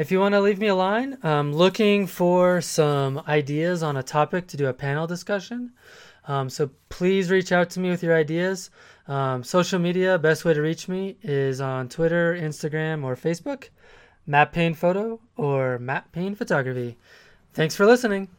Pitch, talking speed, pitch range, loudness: 170 Hz, 180 wpm, 150-190 Hz, -23 LUFS